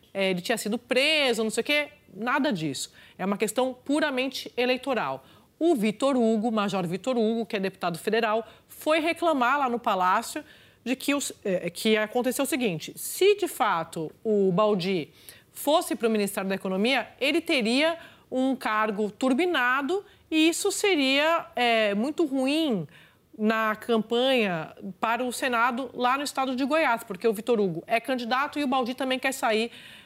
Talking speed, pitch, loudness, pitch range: 160 wpm, 245 Hz, -26 LUFS, 215-280 Hz